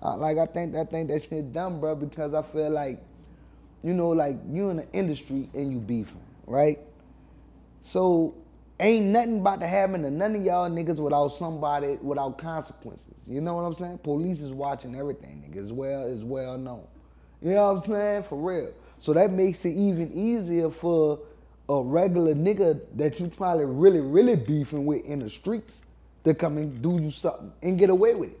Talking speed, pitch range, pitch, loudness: 195 wpm, 140-180 Hz, 155 Hz, -26 LUFS